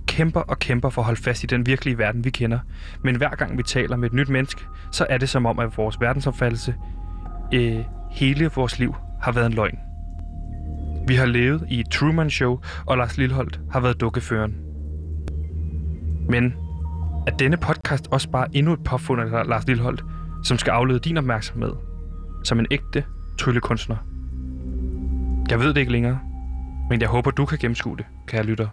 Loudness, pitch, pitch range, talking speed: -23 LUFS, 115 Hz, 80-130 Hz, 180 wpm